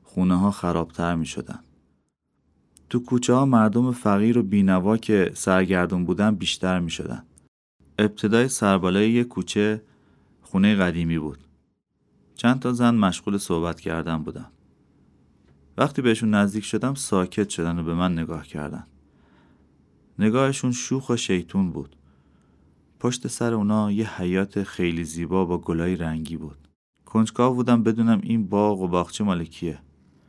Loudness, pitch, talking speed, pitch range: -23 LUFS, 95 Hz, 135 wpm, 80-110 Hz